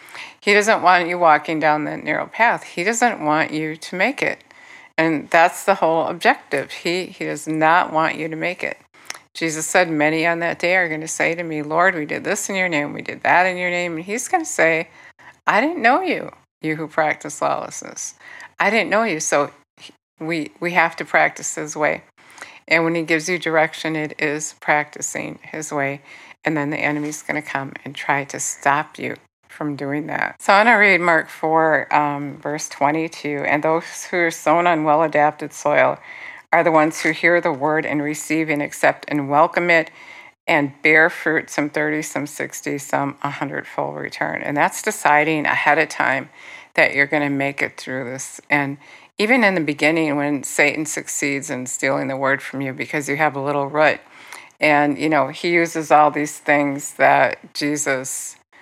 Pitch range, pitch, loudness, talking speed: 145-165 Hz, 155 Hz, -19 LUFS, 195 wpm